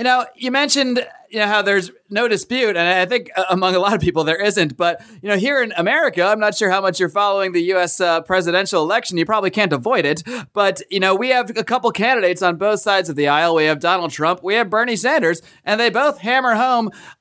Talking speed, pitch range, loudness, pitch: 245 wpm, 180-235 Hz, -17 LUFS, 200 Hz